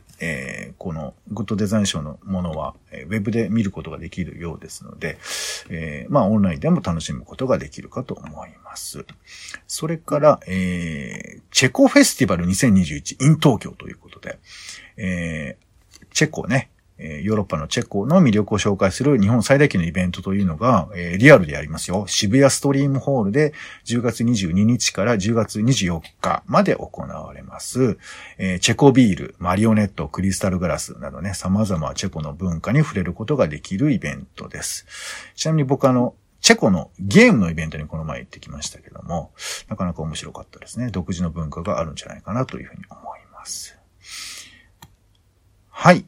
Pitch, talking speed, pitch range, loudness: 100 Hz, 365 characters per minute, 85-120 Hz, -20 LUFS